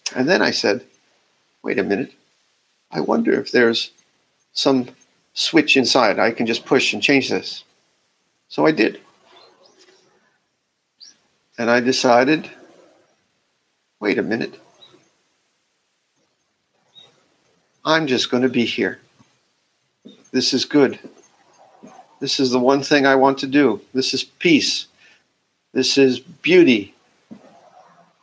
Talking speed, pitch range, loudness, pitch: 115 wpm, 125-140 Hz, -18 LUFS, 130 Hz